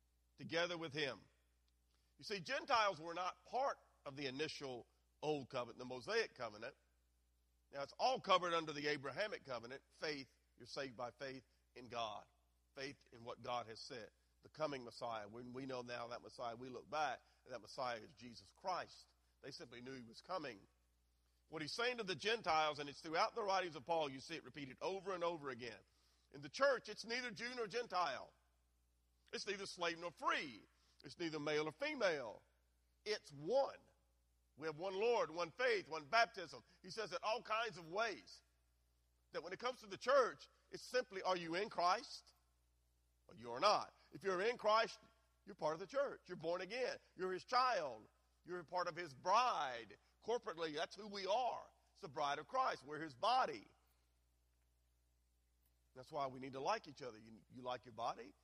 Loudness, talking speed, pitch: -43 LUFS, 185 wpm, 145 Hz